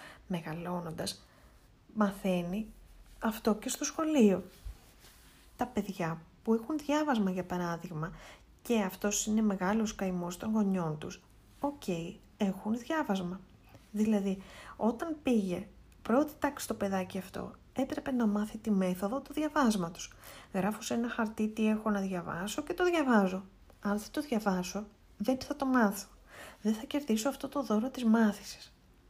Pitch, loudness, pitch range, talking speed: 210 Hz, -33 LUFS, 190-245 Hz, 140 wpm